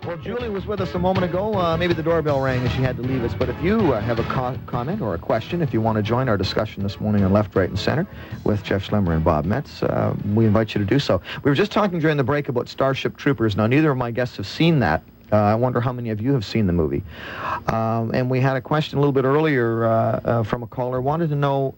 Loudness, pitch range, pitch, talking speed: -21 LUFS, 110-145 Hz, 125 Hz, 285 wpm